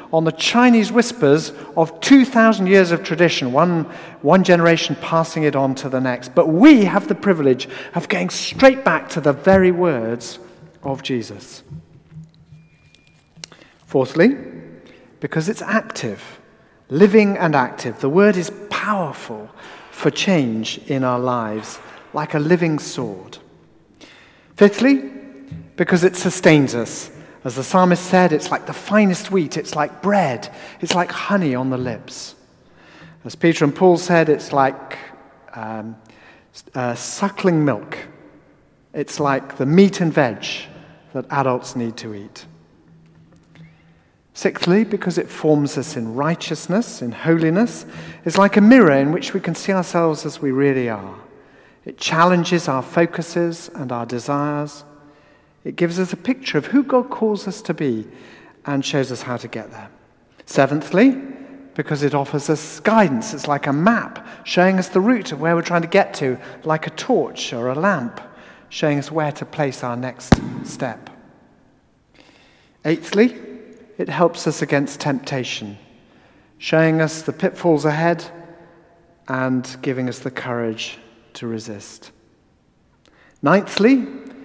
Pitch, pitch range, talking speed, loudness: 160 Hz, 135-185 Hz, 145 wpm, -18 LUFS